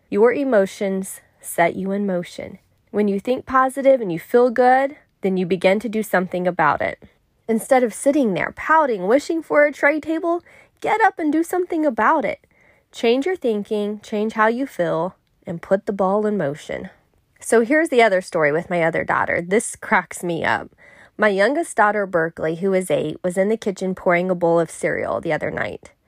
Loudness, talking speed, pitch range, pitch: -20 LUFS, 195 wpm, 185-275 Hz, 215 Hz